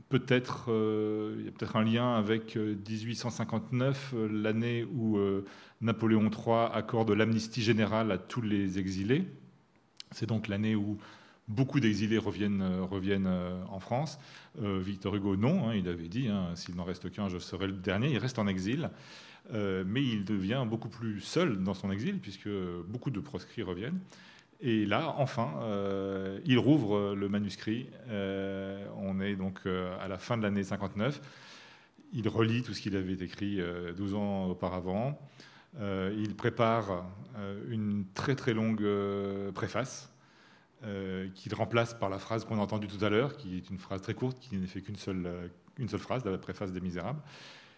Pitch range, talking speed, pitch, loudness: 95-115 Hz, 180 wpm, 105 Hz, -33 LUFS